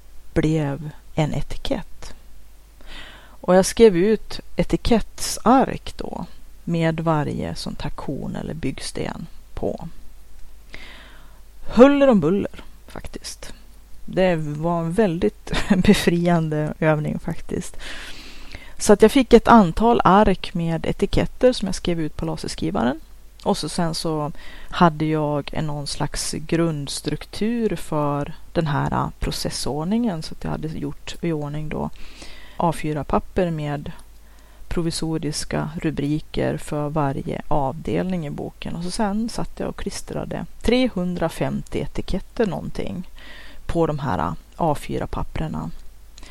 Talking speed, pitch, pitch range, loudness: 110 wpm, 165 Hz, 150-195 Hz, -22 LUFS